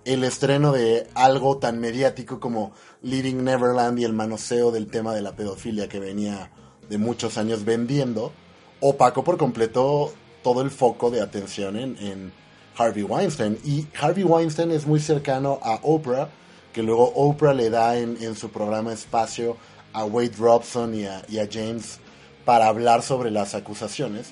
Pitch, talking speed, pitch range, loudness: 115 Hz, 165 wpm, 110-130 Hz, -23 LUFS